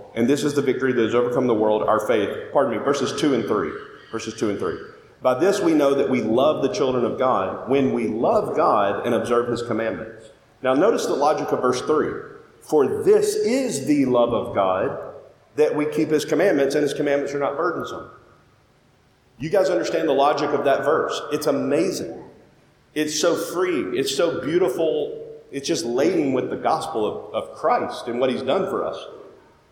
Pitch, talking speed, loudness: 150 Hz, 195 wpm, -21 LUFS